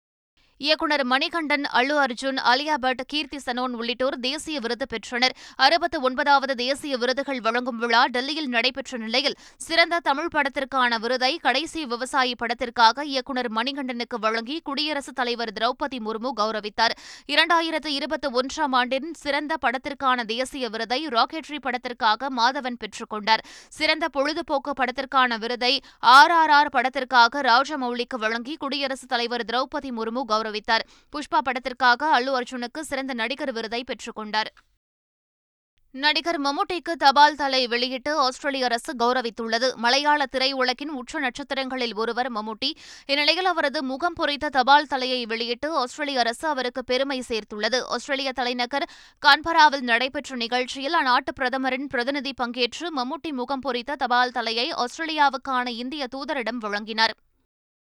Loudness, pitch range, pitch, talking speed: -23 LUFS, 240-290 Hz, 260 Hz, 120 wpm